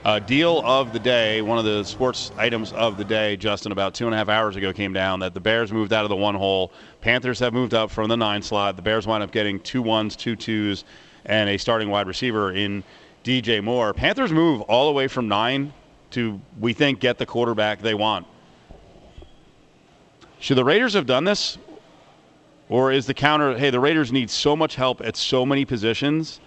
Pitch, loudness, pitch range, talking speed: 115 Hz, -21 LUFS, 105-130 Hz, 210 wpm